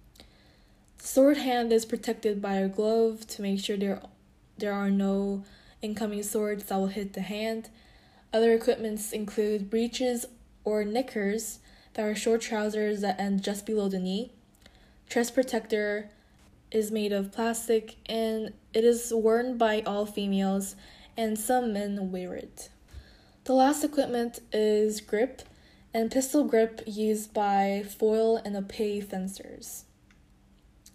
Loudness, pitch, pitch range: -28 LUFS, 215 Hz, 200-230 Hz